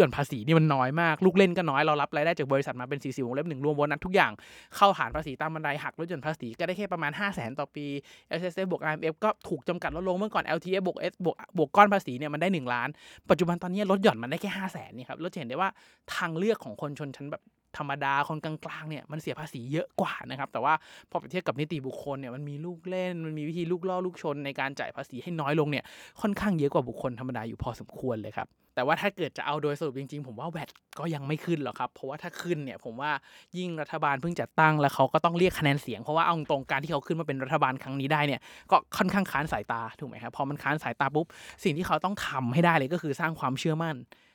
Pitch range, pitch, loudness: 140-175 Hz, 155 Hz, -29 LUFS